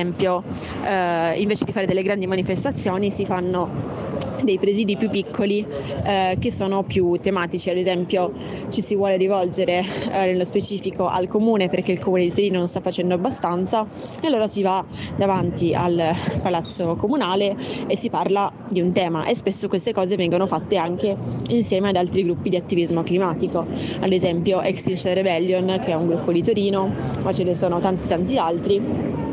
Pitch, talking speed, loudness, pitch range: 185 Hz, 175 wpm, -22 LUFS, 180-200 Hz